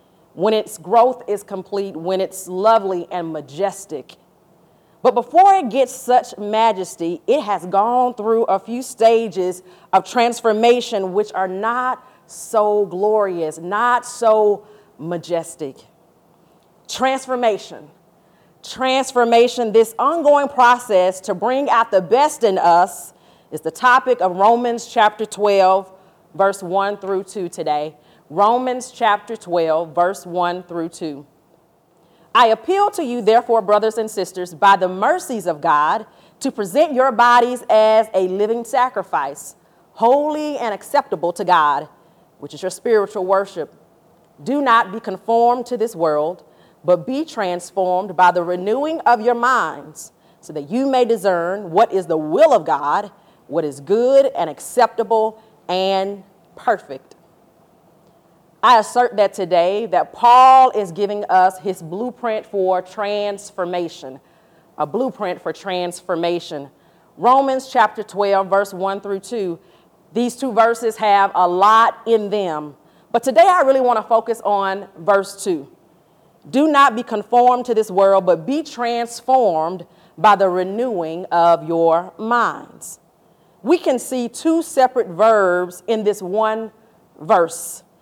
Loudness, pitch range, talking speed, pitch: -17 LUFS, 180-235 Hz, 135 wpm, 205 Hz